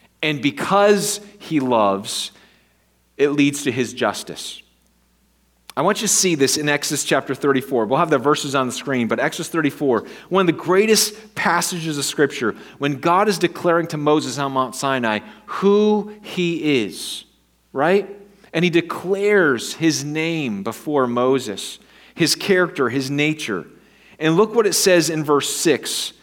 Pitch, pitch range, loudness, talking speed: 150 Hz, 135-185 Hz, -19 LUFS, 155 wpm